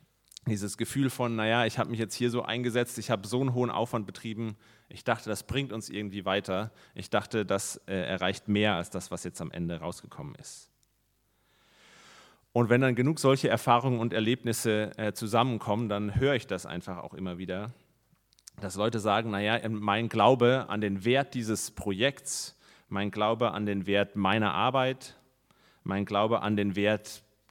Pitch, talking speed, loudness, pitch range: 110 Hz, 175 wpm, -29 LUFS, 100-120 Hz